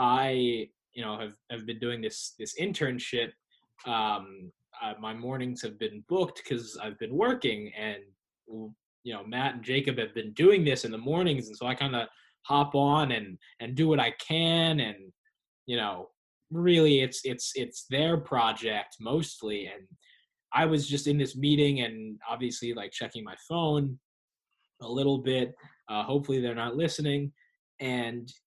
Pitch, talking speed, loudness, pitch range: 130 Hz, 165 wpm, -29 LUFS, 115-150 Hz